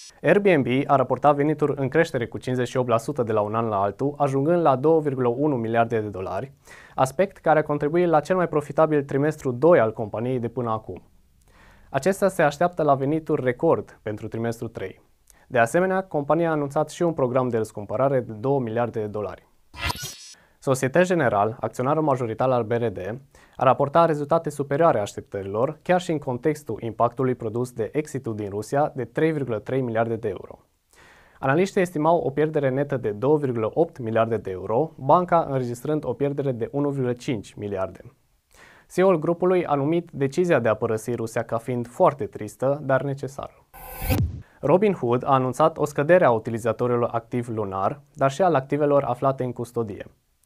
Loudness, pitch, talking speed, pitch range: -23 LUFS, 130 Hz, 160 wpm, 115-150 Hz